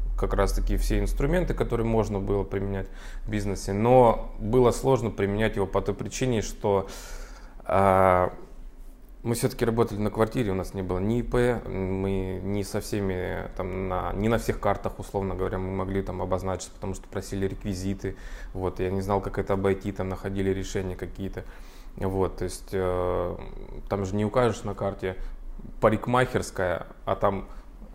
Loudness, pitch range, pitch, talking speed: -27 LUFS, 95-110 Hz, 100 Hz, 165 wpm